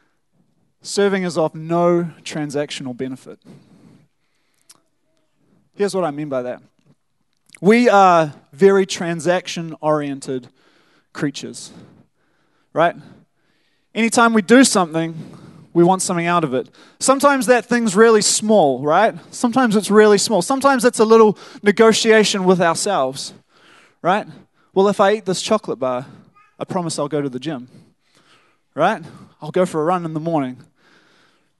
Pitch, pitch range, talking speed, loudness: 180 Hz, 155-215 Hz, 135 wpm, -17 LUFS